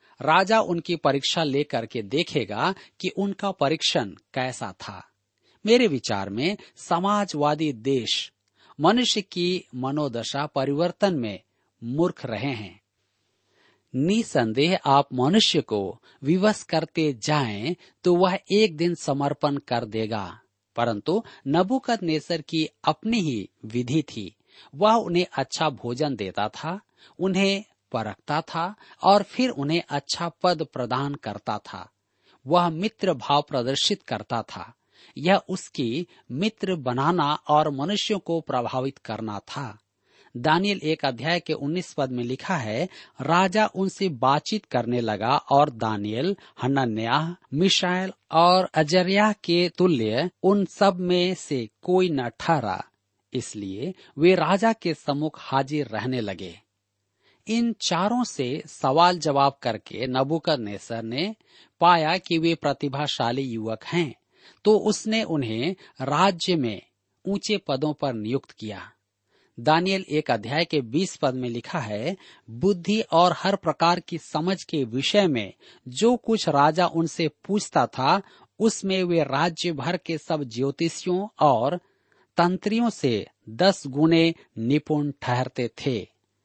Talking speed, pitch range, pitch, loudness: 125 wpm, 130-180 Hz, 155 Hz, -24 LUFS